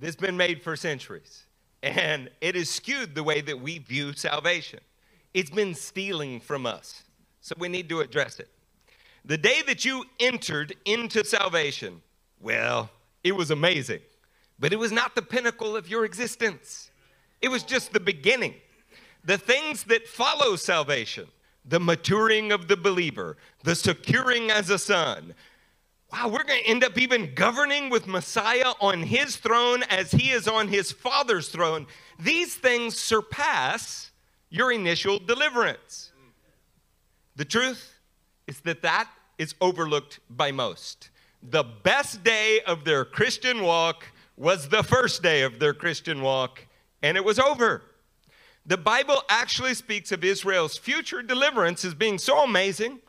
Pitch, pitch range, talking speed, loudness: 200 Hz, 170-235 Hz, 150 wpm, -24 LUFS